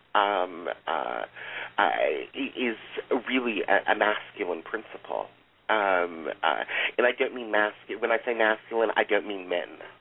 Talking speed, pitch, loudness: 150 wpm, 120 Hz, -27 LUFS